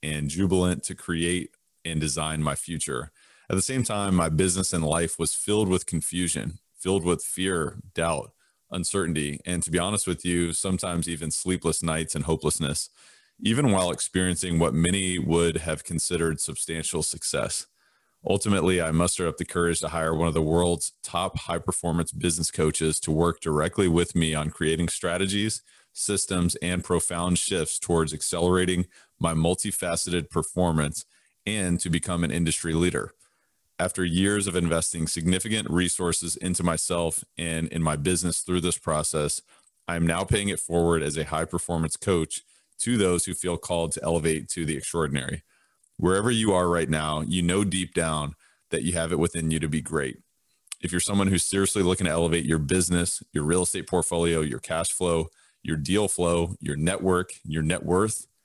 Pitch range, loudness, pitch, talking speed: 80-90 Hz, -26 LUFS, 85 Hz, 170 wpm